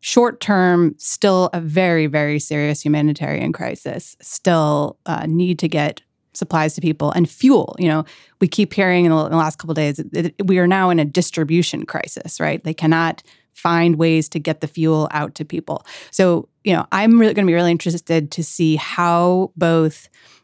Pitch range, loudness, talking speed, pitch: 155-180 Hz, -18 LUFS, 190 wpm, 165 Hz